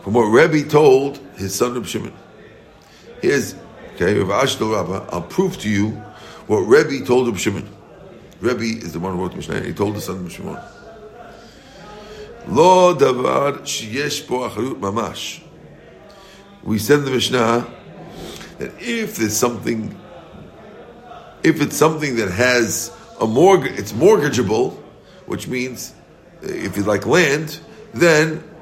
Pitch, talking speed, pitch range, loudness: 135 Hz, 135 wpm, 115-175 Hz, -18 LUFS